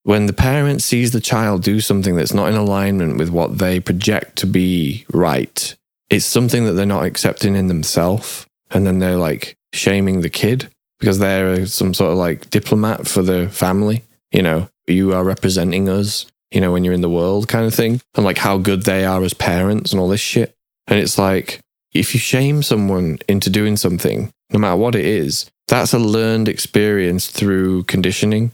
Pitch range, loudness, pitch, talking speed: 90-110 Hz, -16 LUFS, 100 Hz, 195 wpm